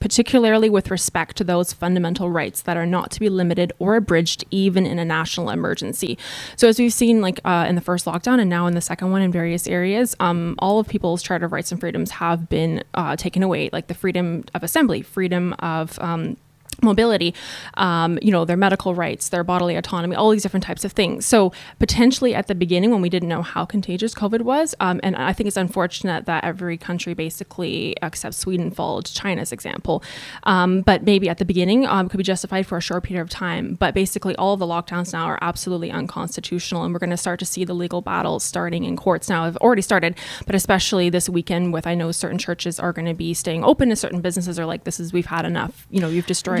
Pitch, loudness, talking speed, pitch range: 180 Hz, -20 LUFS, 230 wpm, 170-195 Hz